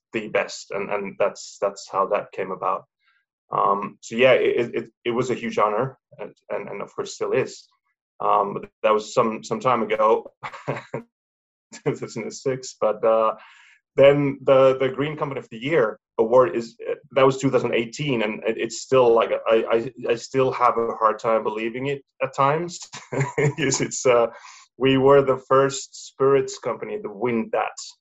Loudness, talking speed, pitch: -22 LUFS, 170 wpm, 140 Hz